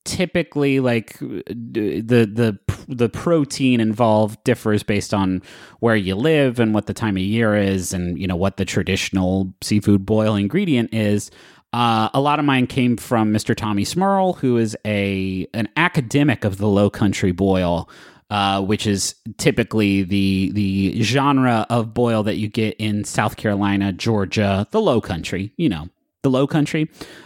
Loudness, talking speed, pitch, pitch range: -19 LUFS, 165 wpm, 110 Hz, 100-120 Hz